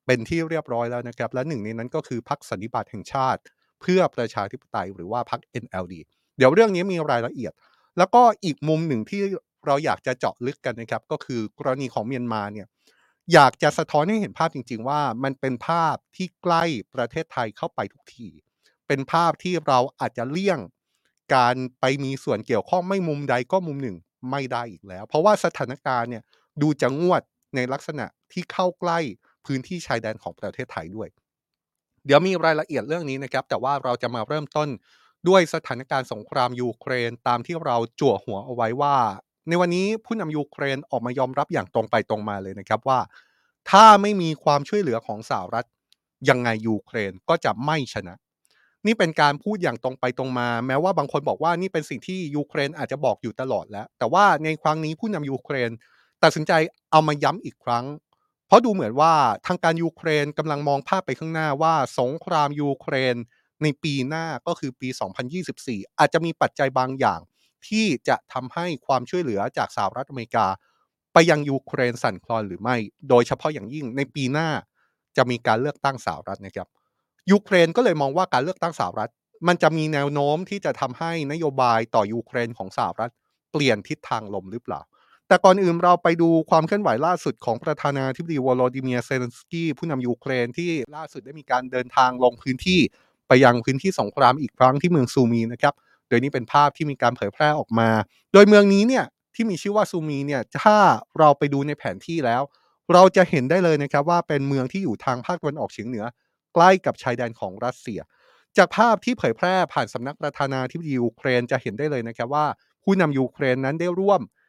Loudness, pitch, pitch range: -22 LUFS, 145 Hz, 125-165 Hz